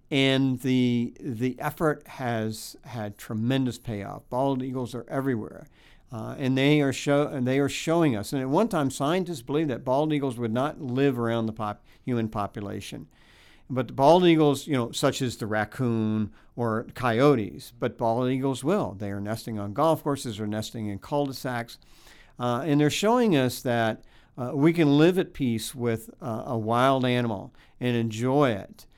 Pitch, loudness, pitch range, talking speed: 125 Hz, -26 LUFS, 115-140 Hz, 175 wpm